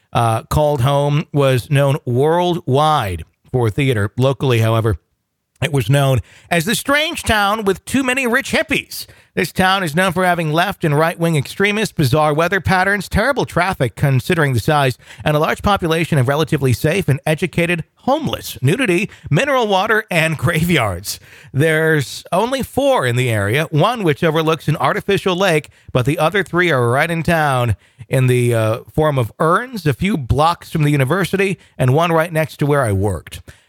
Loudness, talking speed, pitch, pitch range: -16 LUFS, 170 wpm, 155 Hz, 130-175 Hz